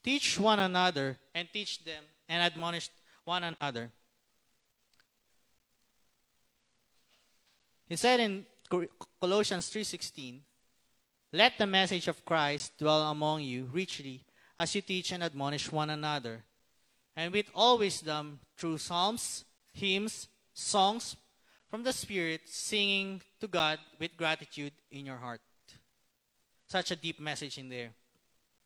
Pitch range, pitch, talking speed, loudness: 135-190 Hz, 160 Hz, 115 wpm, -32 LUFS